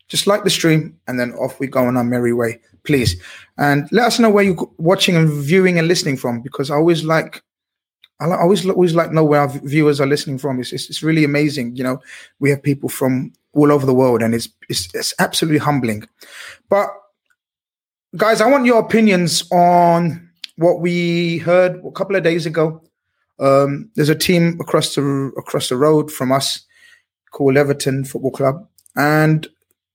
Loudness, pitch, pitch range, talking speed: -16 LUFS, 155 Hz, 135-175 Hz, 190 wpm